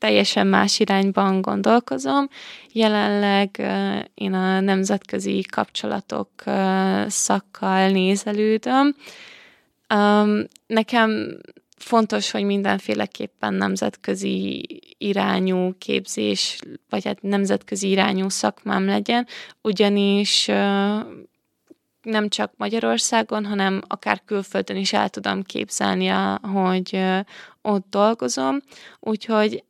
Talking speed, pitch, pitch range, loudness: 75 wpm, 200 Hz, 185-215 Hz, -21 LUFS